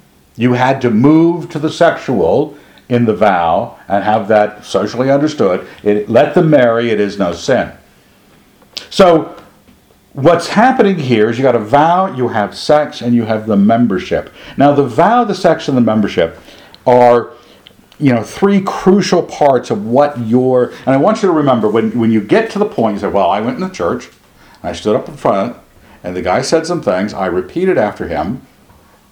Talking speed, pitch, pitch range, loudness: 190 wpm, 125 Hz, 110-165 Hz, -13 LUFS